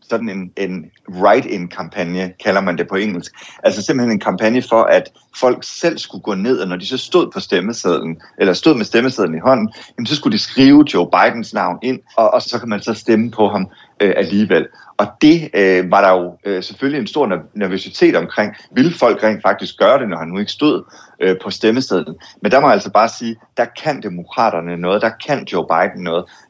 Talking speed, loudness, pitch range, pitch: 200 wpm, -16 LUFS, 90-125 Hz, 105 Hz